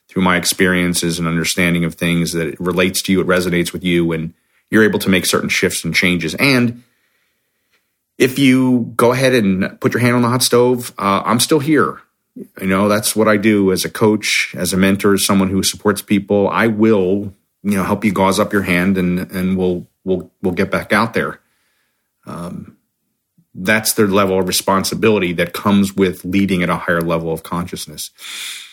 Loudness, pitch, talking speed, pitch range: -15 LUFS, 95 Hz, 195 wpm, 90-110 Hz